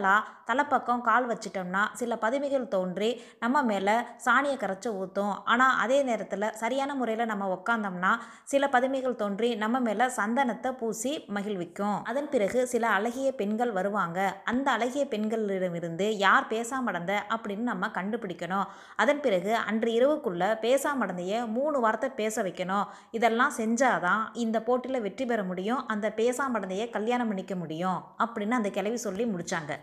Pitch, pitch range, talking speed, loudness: 225 Hz, 200-250 Hz, 135 wpm, -28 LUFS